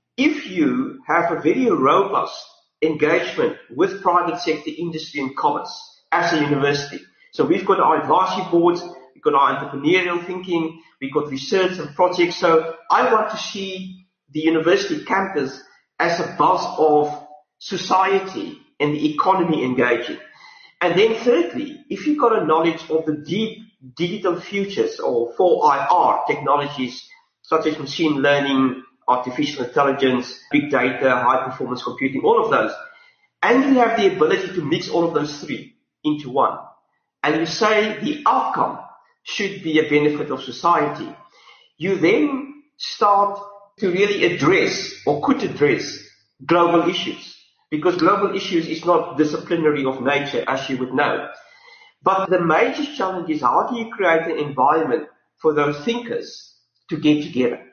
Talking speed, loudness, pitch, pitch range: 150 wpm, -19 LUFS, 170 Hz, 150-215 Hz